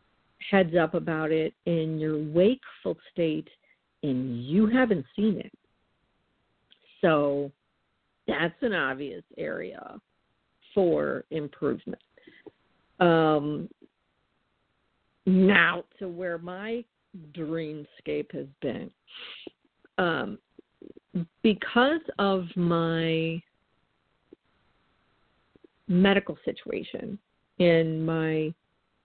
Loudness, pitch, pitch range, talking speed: -27 LUFS, 165 Hz, 155-195 Hz, 75 wpm